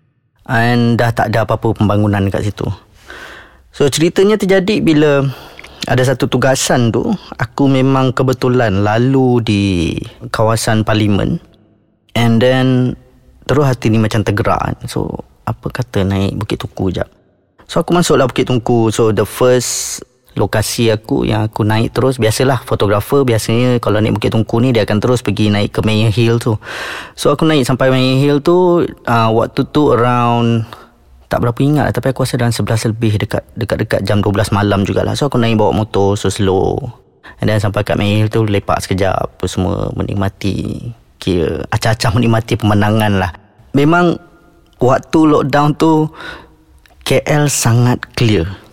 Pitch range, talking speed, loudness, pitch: 105-130 Hz, 155 wpm, -14 LUFS, 115 Hz